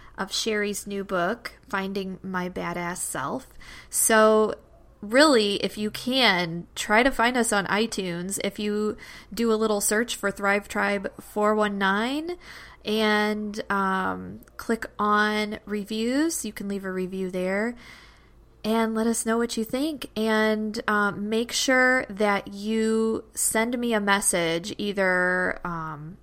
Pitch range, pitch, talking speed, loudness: 195-225 Hz, 210 Hz, 135 wpm, -24 LUFS